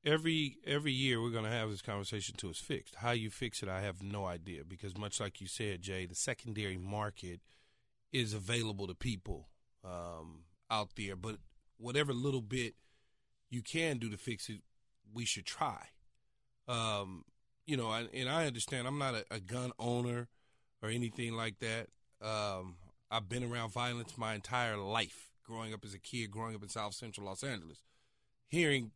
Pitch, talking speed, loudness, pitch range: 115 Hz, 180 wpm, -39 LUFS, 100-120 Hz